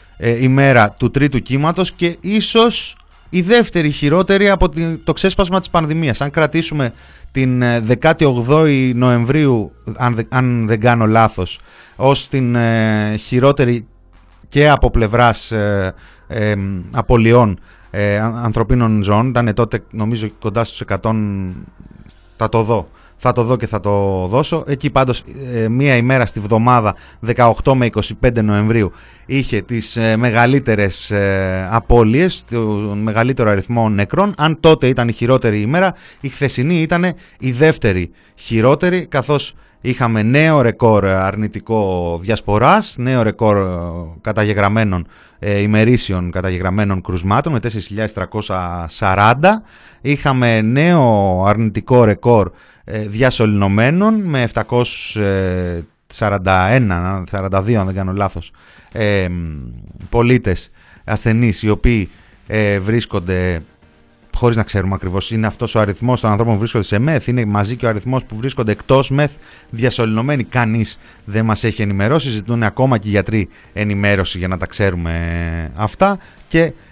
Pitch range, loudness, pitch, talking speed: 100-130 Hz, -15 LUFS, 115 Hz, 115 wpm